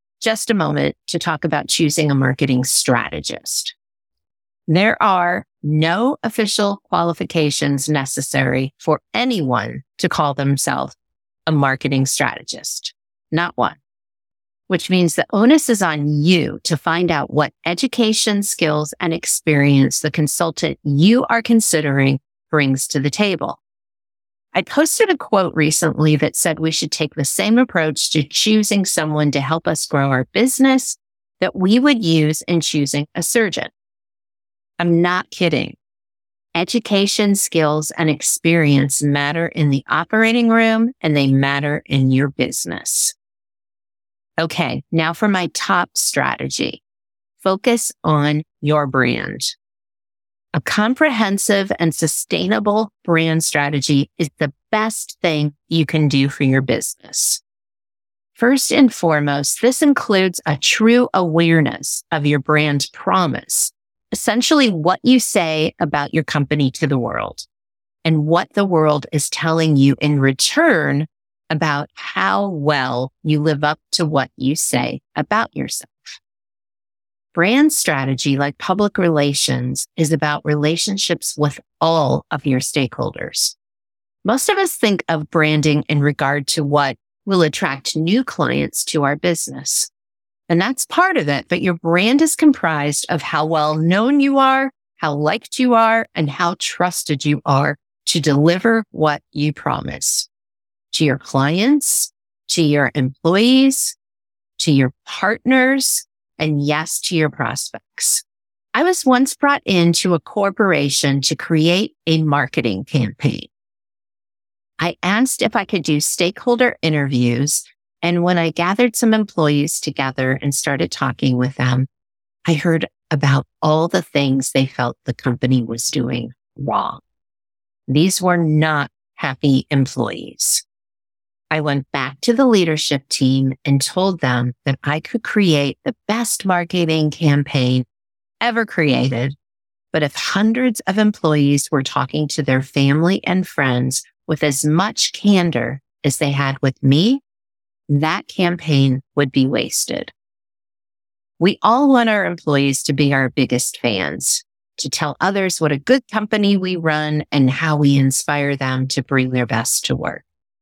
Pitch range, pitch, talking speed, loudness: 135-185 Hz, 155 Hz, 135 wpm, -17 LUFS